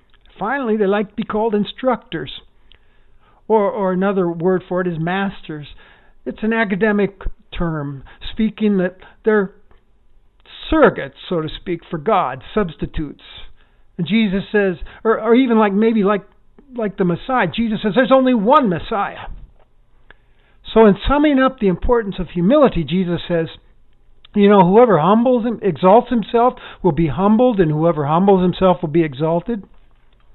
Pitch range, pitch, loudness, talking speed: 180-225 Hz, 200 Hz, -17 LUFS, 145 wpm